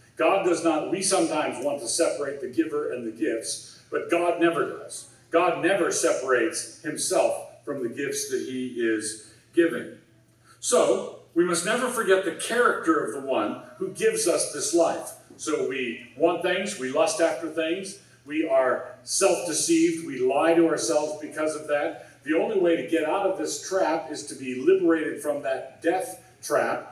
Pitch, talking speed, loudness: 170 Hz, 175 wpm, -25 LUFS